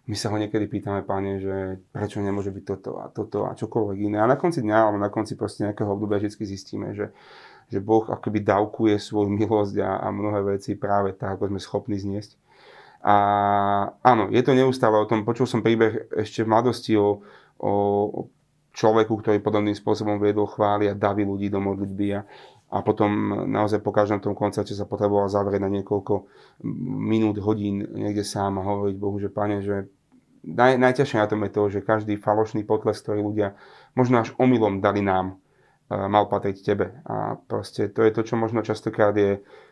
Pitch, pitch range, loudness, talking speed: 105 Hz, 100-110 Hz, -24 LUFS, 185 wpm